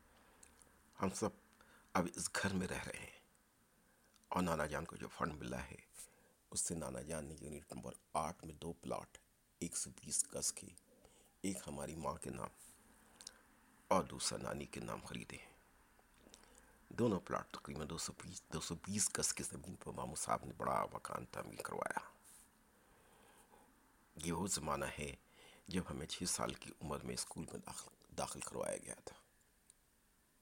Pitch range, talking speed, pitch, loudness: 70-85 Hz, 165 wpm, 80 Hz, -43 LUFS